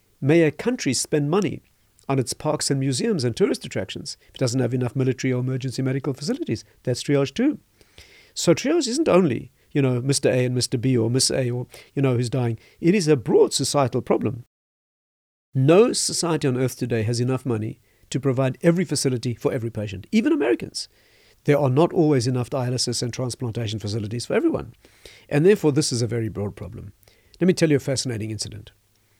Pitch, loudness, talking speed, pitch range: 130 Hz, -22 LUFS, 195 wpm, 115-145 Hz